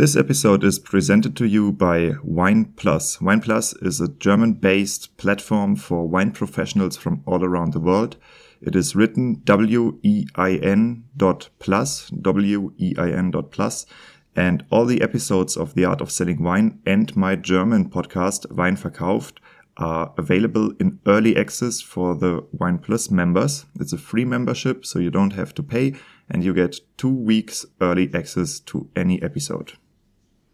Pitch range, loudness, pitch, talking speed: 90-120 Hz, -20 LUFS, 100 Hz, 165 wpm